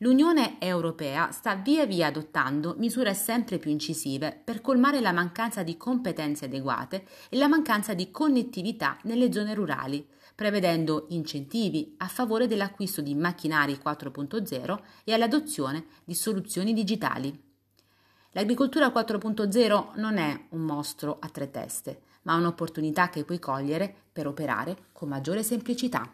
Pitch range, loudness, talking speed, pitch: 150-225 Hz, -28 LUFS, 130 wpm, 180 Hz